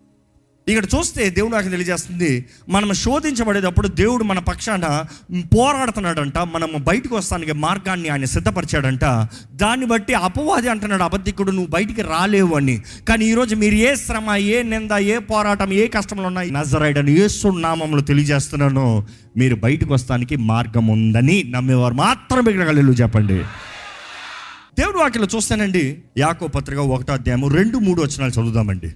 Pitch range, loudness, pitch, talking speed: 135-210 Hz, -18 LUFS, 170 Hz, 130 wpm